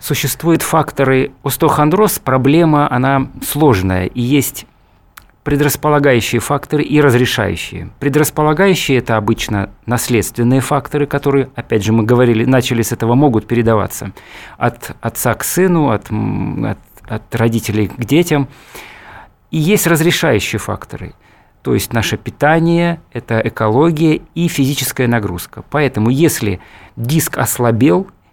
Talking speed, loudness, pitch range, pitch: 115 wpm, -14 LUFS, 115-150 Hz, 130 Hz